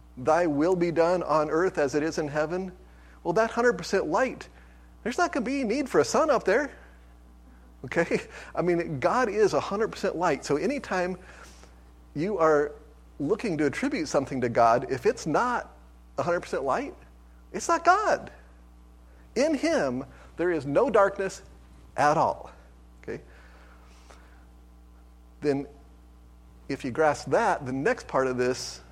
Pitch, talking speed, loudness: 120 Hz, 145 wpm, -26 LUFS